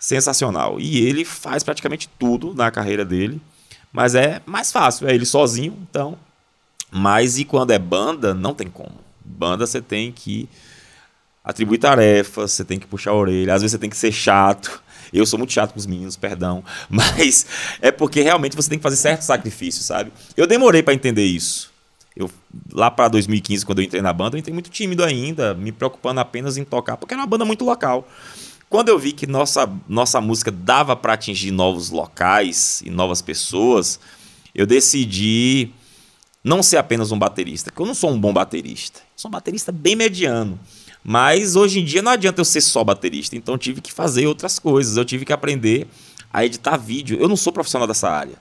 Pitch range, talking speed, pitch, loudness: 105-150 Hz, 195 wpm, 125 Hz, -18 LUFS